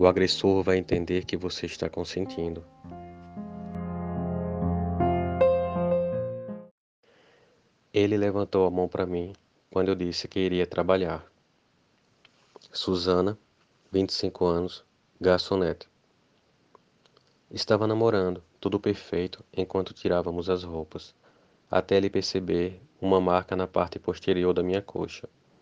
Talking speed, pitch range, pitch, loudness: 100 wpm, 85-100 Hz, 90 Hz, -27 LUFS